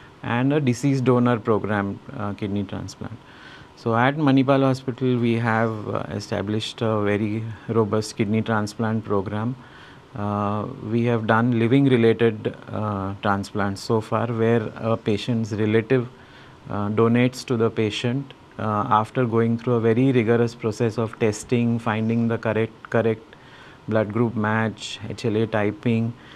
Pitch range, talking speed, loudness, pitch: 105-125 Hz, 135 wpm, -23 LUFS, 115 Hz